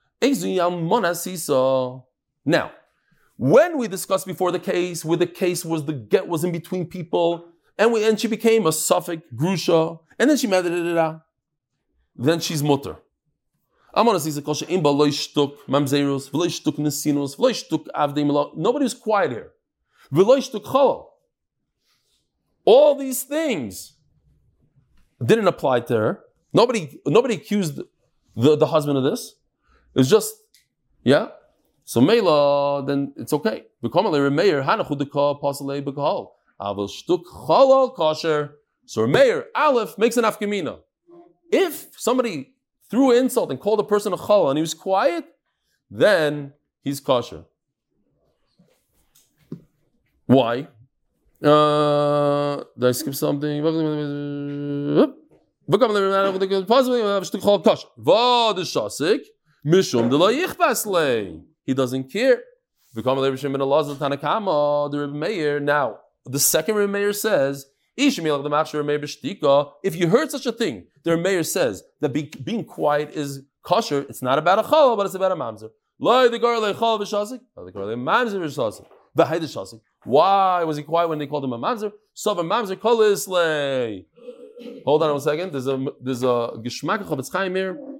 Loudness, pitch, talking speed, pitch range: -21 LUFS, 165 Hz, 105 wpm, 145-220 Hz